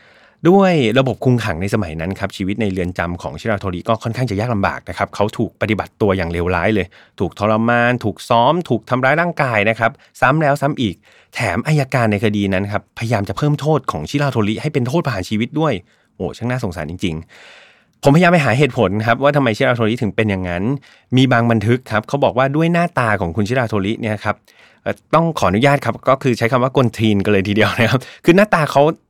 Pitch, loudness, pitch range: 115 Hz, -17 LUFS, 100-135 Hz